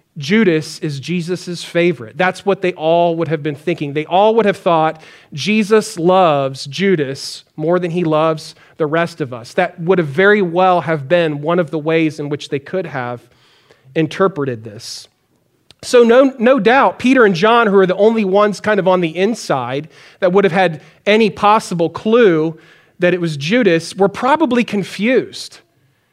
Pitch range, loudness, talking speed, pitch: 155-195 Hz, -15 LUFS, 175 wpm, 175 Hz